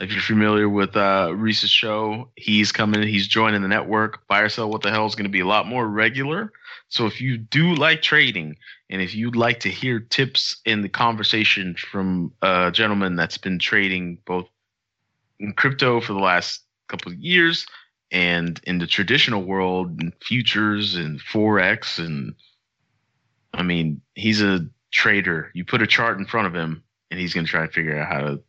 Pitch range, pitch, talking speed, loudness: 90-115 Hz, 105 Hz, 190 wpm, -20 LUFS